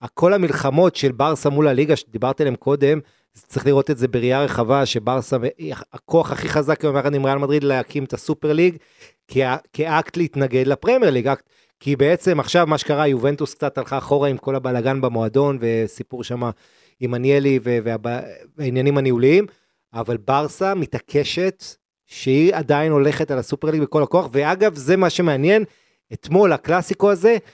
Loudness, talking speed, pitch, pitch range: -19 LUFS, 155 wpm, 140 Hz, 130-155 Hz